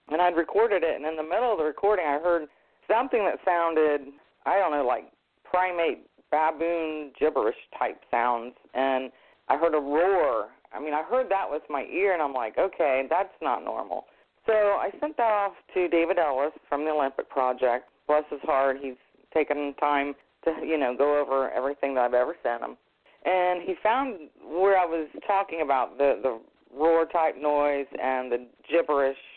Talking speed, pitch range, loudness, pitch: 185 wpm, 140-180 Hz, -26 LUFS, 155 Hz